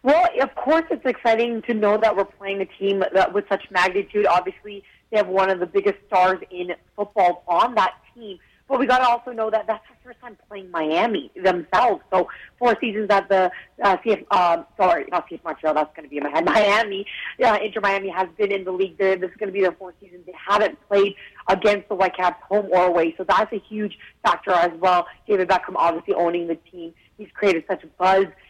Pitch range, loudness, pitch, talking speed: 180-210 Hz, -21 LUFS, 195 Hz, 225 wpm